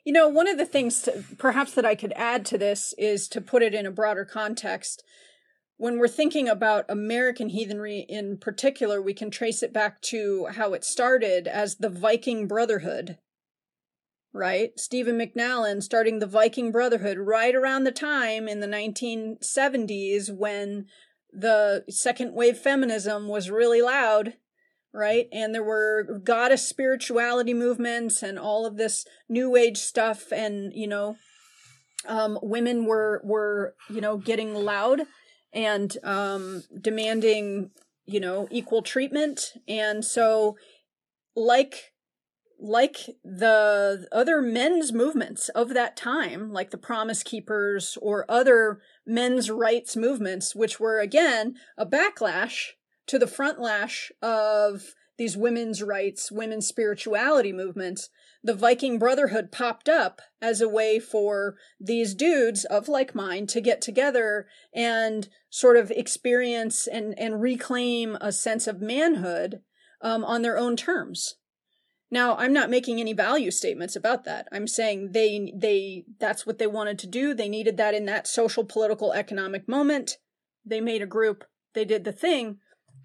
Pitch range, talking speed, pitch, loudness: 210-245 Hz, 145 wpm, 225 Hz, -25 LUFS